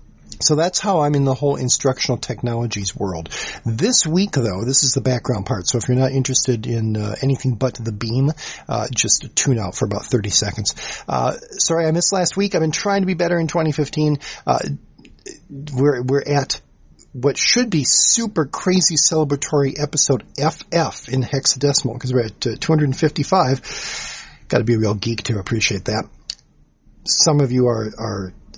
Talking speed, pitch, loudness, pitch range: 175 wpm, 135 Hz, -18 LUFS, 115-155 Hz